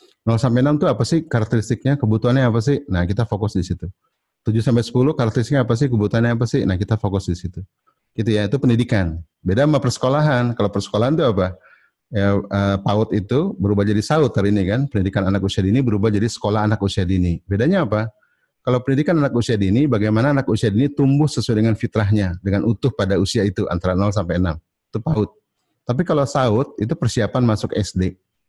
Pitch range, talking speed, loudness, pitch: 100-130 Hz, 195 wpm, -19 LUFS, 110 Hz